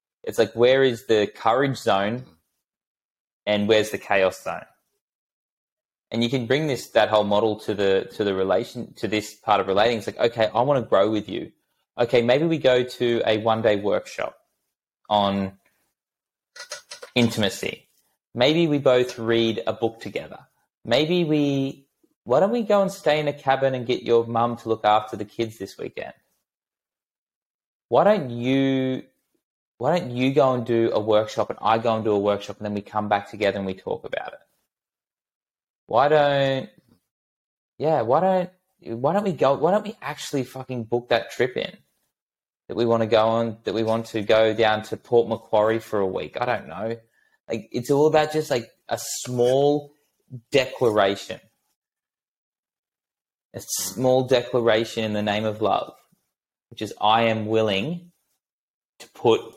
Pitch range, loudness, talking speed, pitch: 110-135 Hz, -22 LUFS, 170 wpm, 115 Hz